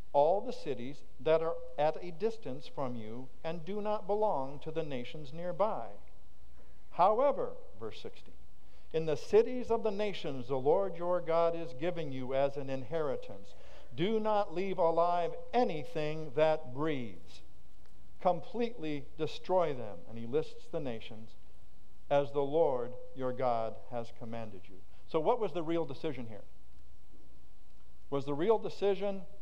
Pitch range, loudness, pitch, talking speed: 125-180 Hz, -34 LUFS, 155 Hz, 145 wpm